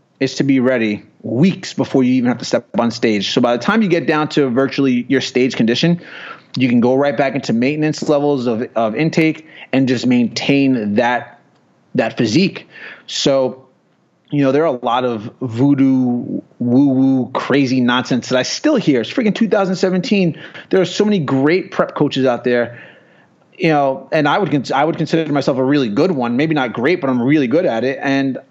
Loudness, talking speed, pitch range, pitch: -16 LUFS, 200 wpm, 125-155 Hz, 135 Hz